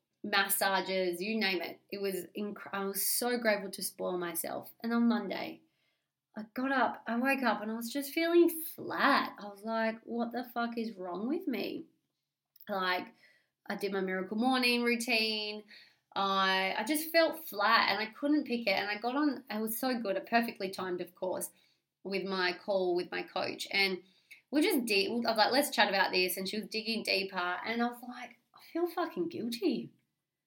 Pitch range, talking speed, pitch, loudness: 195-245 Hz, 195 wpm, 215 Hz, -32 LUFS